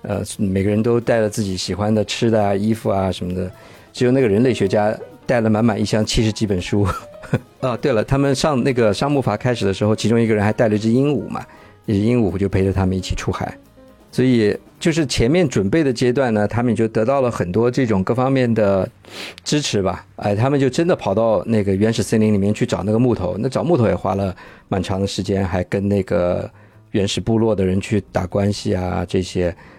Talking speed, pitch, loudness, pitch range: 330 characters per minute, 105 Hz, -19 LUFS, 100-120 Hz